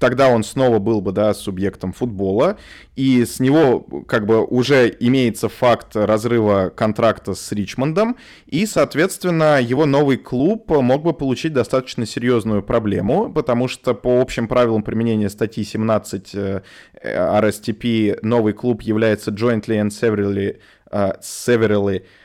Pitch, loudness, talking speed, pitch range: 115 Hz, -18 LUFS, 130 wpm, 105-125 Hz